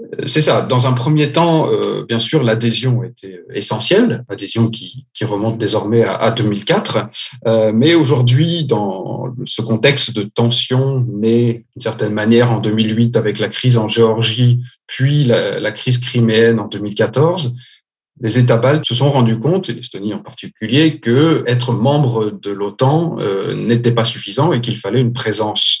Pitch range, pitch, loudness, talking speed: 110-130 Hz, 120 Hz, -14 LUFS, 165 wpm